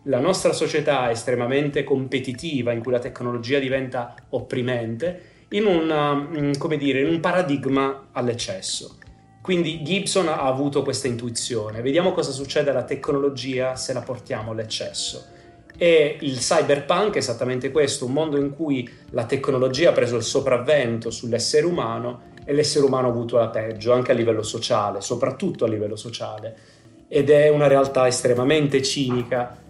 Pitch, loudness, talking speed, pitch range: 135 Hz, -22 LUFS, 150 wpm, 120-145 Hz